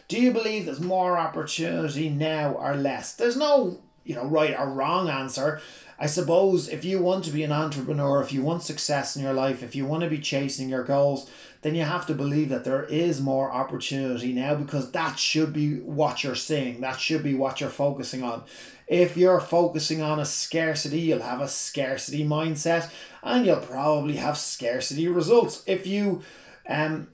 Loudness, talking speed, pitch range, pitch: -25 LUFS, 190 wpm, 140-165 Hz, 150 Hz